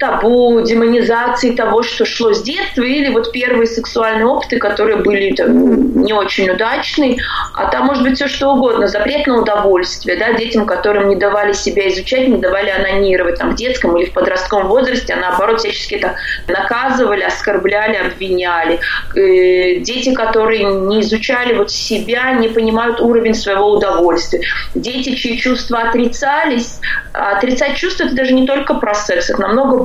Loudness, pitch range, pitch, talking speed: -13 LUFS, 205-255 Hz, 230 Hz, 155 wpm